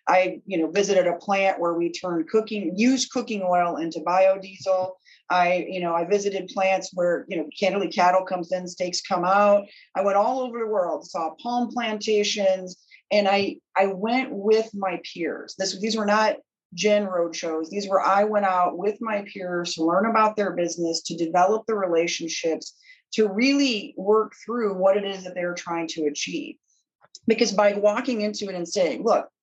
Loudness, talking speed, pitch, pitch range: -24 LUFS, 185 wpm, 190 Hz, 175-215 Hz